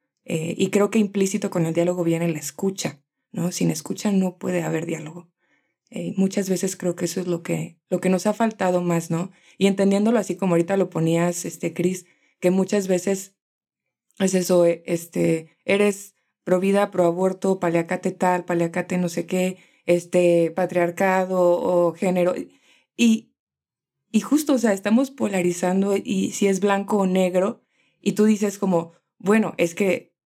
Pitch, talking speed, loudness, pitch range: 185 Hz, 175 wpm, -22 LUFS, 175-200 Hz